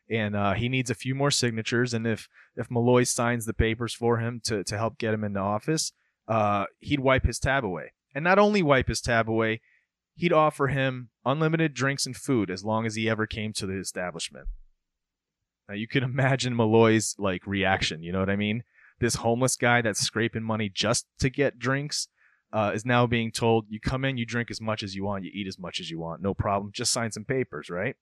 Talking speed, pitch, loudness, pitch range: 225 wpm, 115 Hz, -26 LUFS, 105-130 Hz